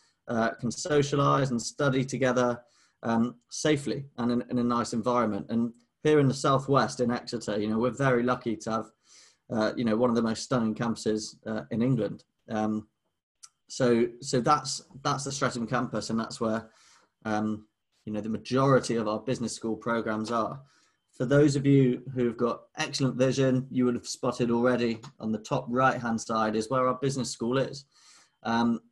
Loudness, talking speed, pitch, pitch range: -28 LUFS, 185 wpm, 120 Hz, 115-130 Hz